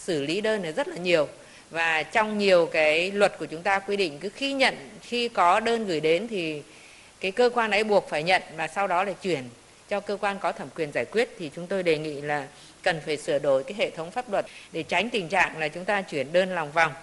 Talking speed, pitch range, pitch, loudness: 255 wpm, 160-205 Hz, 185 Hz, -25 LUFS